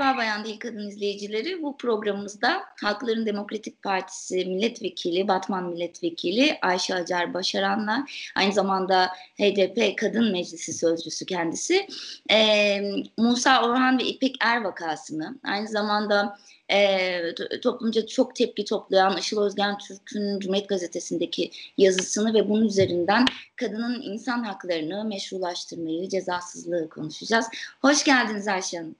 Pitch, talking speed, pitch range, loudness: 205 Hz, 110 wpm, 185-235 Hz, -25 LUFS